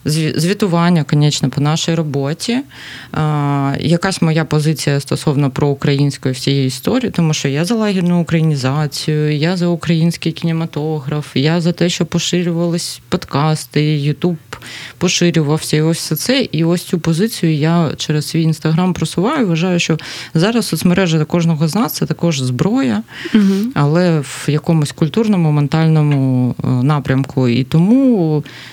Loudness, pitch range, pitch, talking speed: -15 LUFS, 150-175 Hz, 160 Hz, 125 wpm